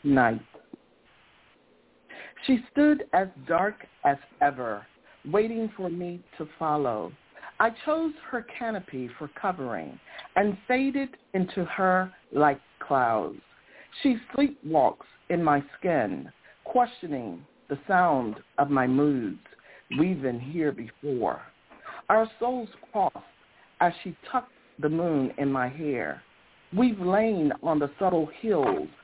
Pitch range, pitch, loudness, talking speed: 145-225 Hz, 180 Hz, -27 LUFS, 115 wpm